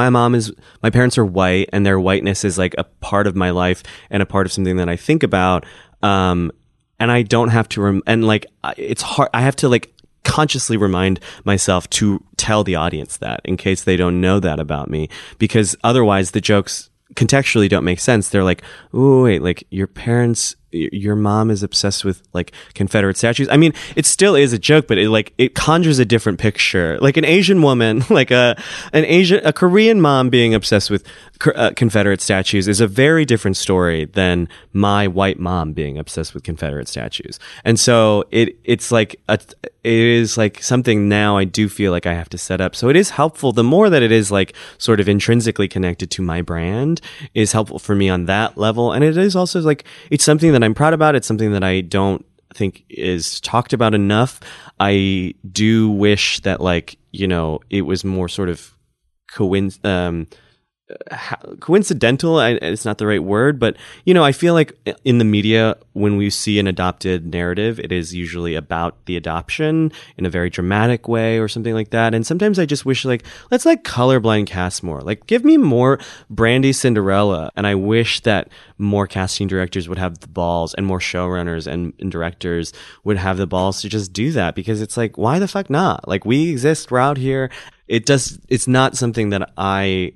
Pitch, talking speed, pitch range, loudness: 105 Hz, 200 wpm, 95-125 Hz, -16 LUFS